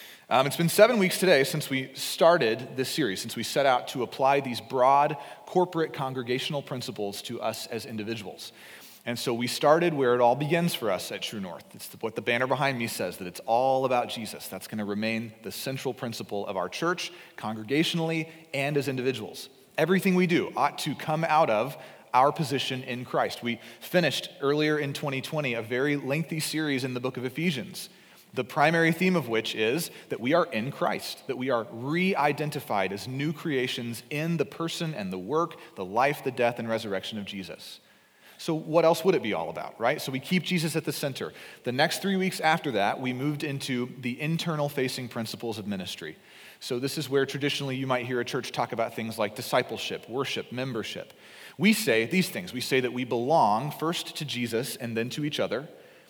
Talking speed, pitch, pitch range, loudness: 205 wpm, 135 Hz, 120-160 Hz, -28 LUFS